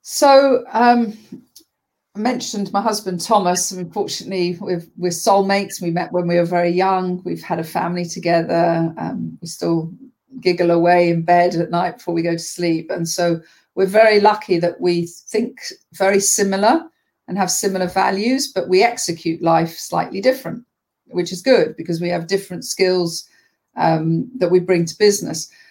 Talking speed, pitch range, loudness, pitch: 170 wpm, 170-215 Hz, -18 LUFS, 180 Hz